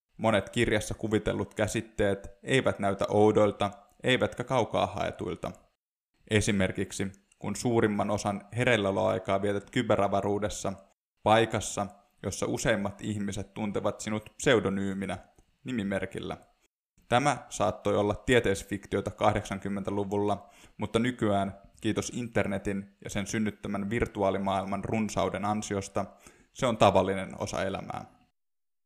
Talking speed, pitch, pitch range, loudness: 95 wpm, 100 Hz, 100-110 Hz, -29 LUFS